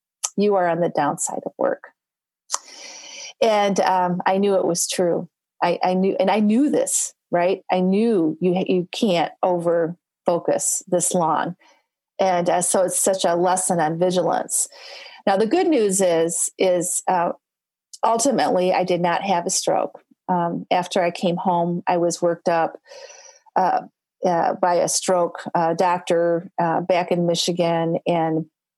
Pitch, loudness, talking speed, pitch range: 180 Hz, -21 LUFS, 155 wpm, 170-190 Hz